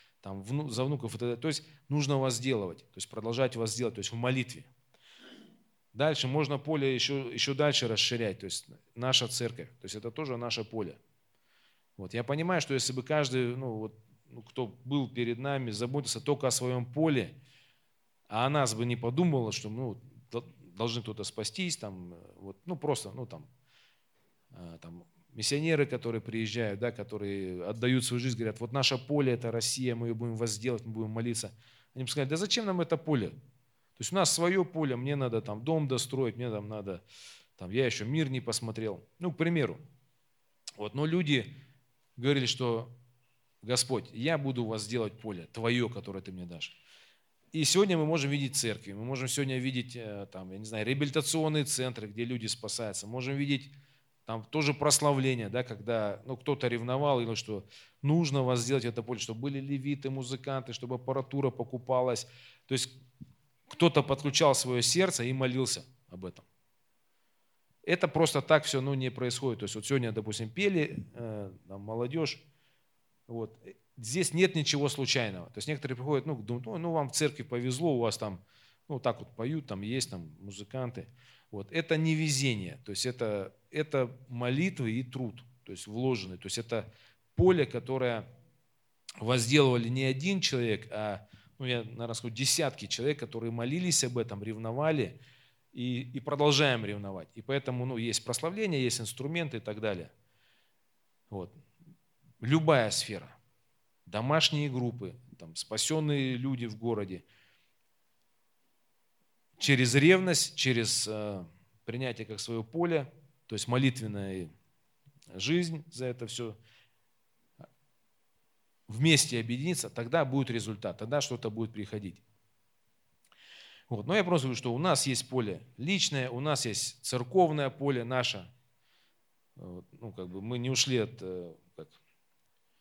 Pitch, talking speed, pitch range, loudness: 125 Hz, 155 wpm, 115-140 Hz, -31 LUFS